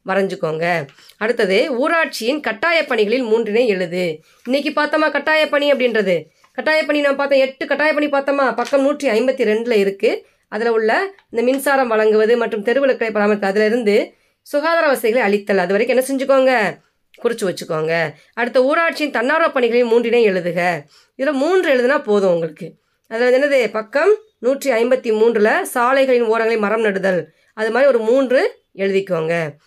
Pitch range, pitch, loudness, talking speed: 205-280 Hz, 240 Hz, -17 LUFS, 110 wpm